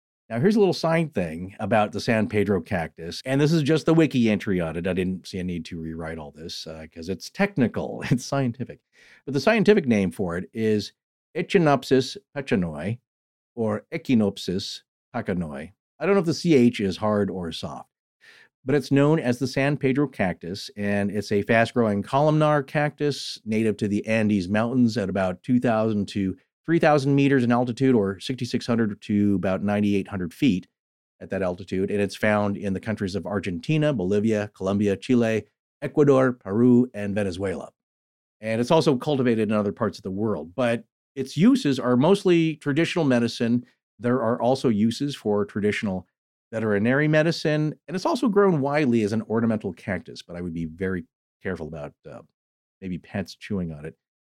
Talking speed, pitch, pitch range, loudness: 175 wpm, 110 Hz, 100-140 Hz, -24 LUFS